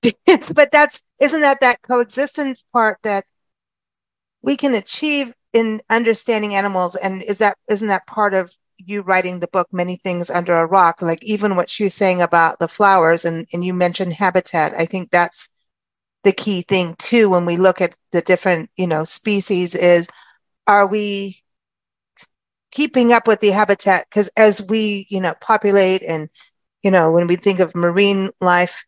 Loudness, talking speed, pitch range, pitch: -16 LUFS, 170 wpm, 175-215 Hz, 195 Hz